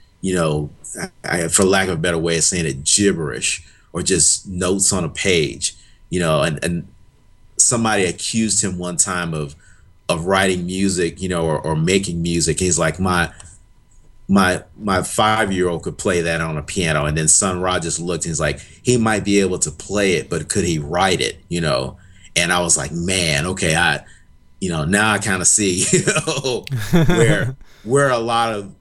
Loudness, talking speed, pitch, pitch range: -18 LUFS, 200 wpm, 90 Hz, 85-100 Hz